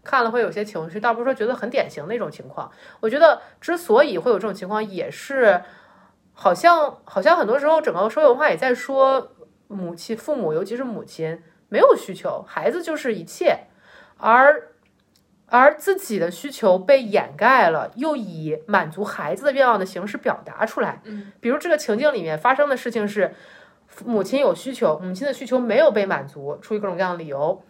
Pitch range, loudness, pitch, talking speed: 195-285 Hz, -20 LUFS, 235 Hz, 295 characters per minute